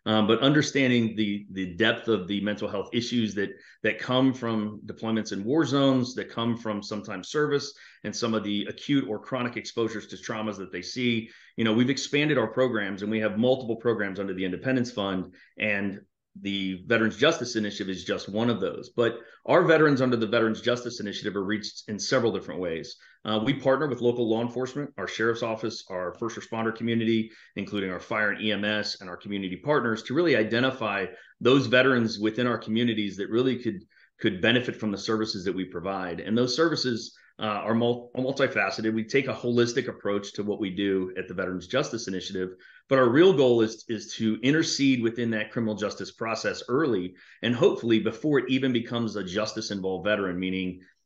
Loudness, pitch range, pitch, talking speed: -27 LUFS, 100-120 Hz, 110 Hz, 195 wpm